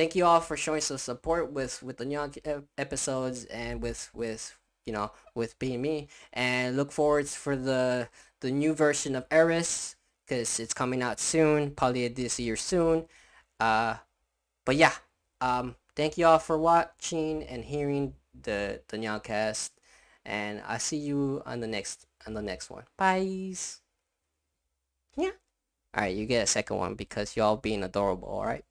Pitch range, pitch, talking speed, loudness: 115-155 Hz, 130 Hz, 165 wpm, -29 LUFS